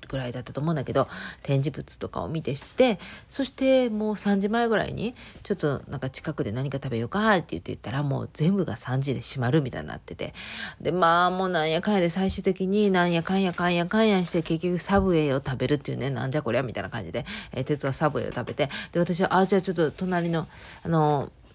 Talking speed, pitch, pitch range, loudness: 470 characters per minute, 165 Hz, 135-190 Hz, -26 LUFS